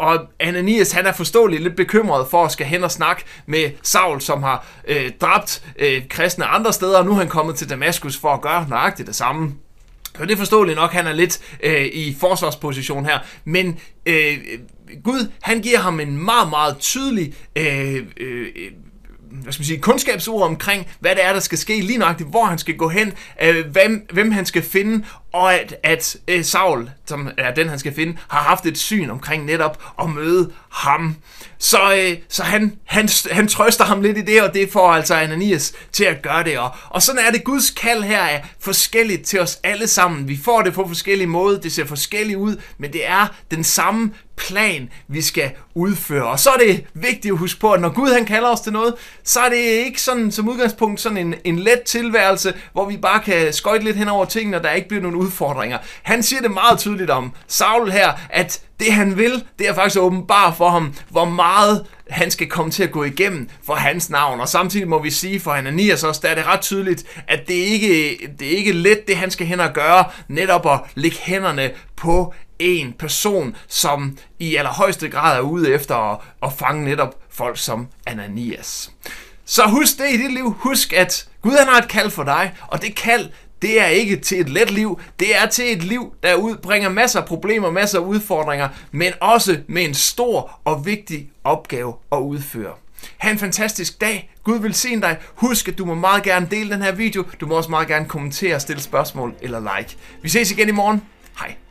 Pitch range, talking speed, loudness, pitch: 155-210 Hz, 210 wpm, -17 LUFS, 180 Hz